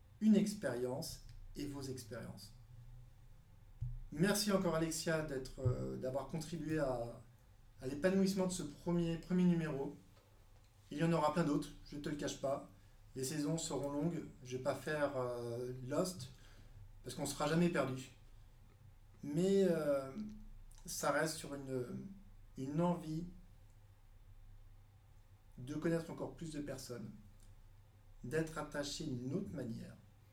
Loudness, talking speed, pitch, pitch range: -39 LUFS, 130 wpm, 130 Hz, 105-155 Hz